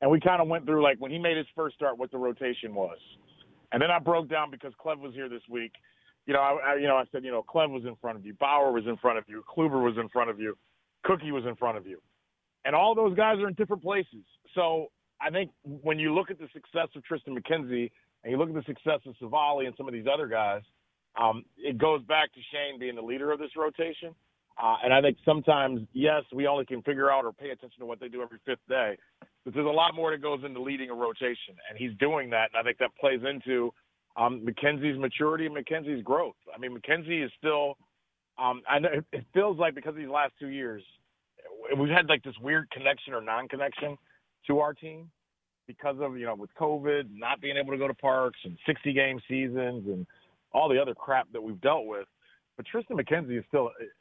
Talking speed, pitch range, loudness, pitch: 240 wpm, 125-155 Hz, -29 LUFS, 140 Hz